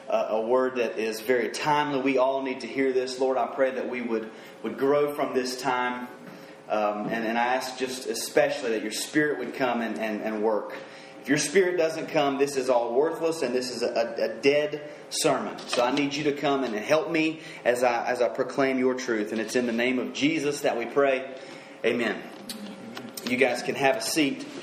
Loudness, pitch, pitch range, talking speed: -26 LUFS, 130 Hz, 120-145 Hz, 215 wpm